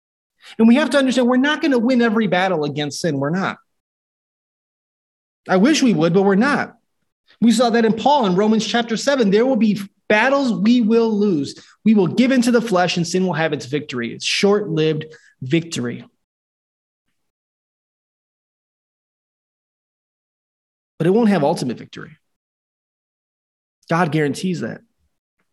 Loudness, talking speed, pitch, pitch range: -17 LUFS, 150 wpm, 200 Hz, 150-235 Hz